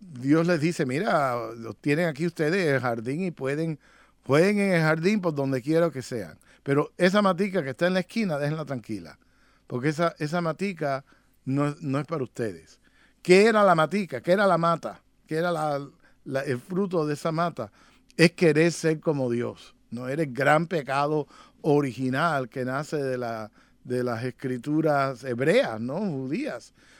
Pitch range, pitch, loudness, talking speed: 130-170 Hz, 150 Hz, -25 LUFS, 170 wpm